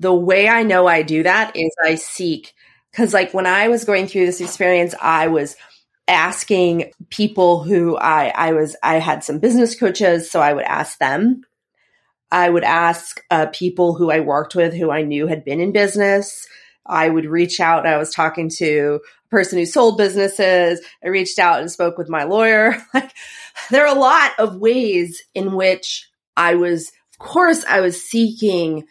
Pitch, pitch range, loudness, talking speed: 180 Hz, 165-205 Hz, -16 LUFS, 185 wpm